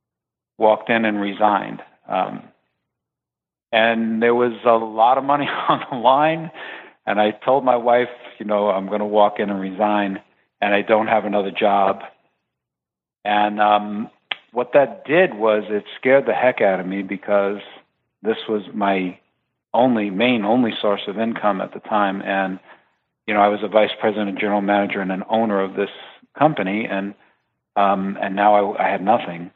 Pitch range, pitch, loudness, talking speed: 100-115 Hz, 105 Hz, -19 LUFS, 175 wpm